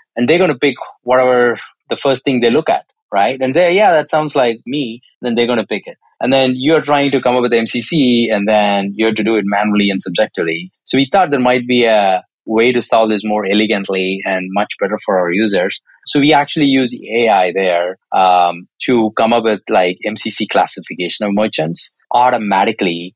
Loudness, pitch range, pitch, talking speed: -14 LUFS, 100-130 Hz, 115 Hz, 210 wpm